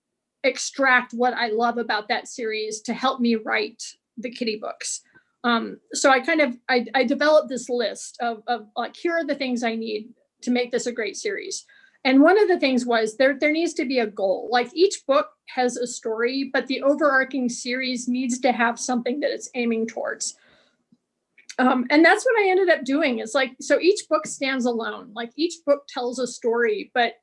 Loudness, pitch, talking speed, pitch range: -22 LUFS, 255 Hz, 205 wpm, 240-290 Hz